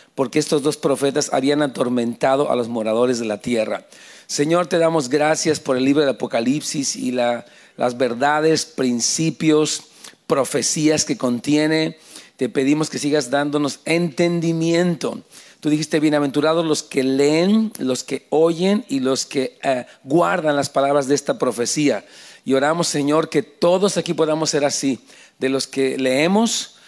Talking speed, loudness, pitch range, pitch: 150 wpm, -19 LUFS, 135-160 Hz, 150 Hz